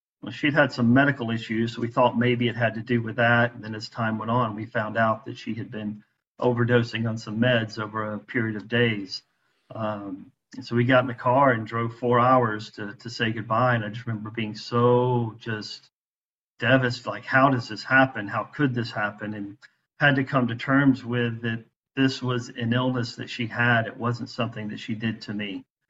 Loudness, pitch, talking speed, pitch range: -24 LUFS, 115 Hz, 220 wpm, 110-125 Hz